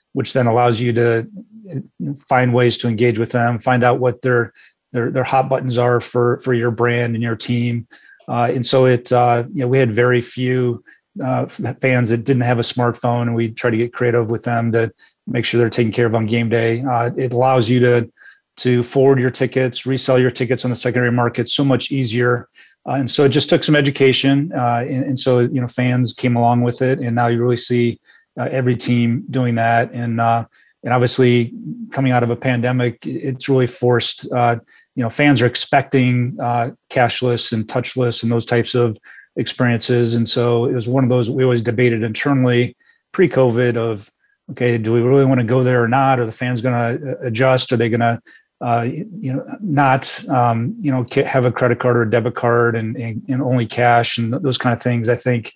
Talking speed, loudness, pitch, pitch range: 215 wpm, -17 LUFS, 125 Hz, 120-130 Hz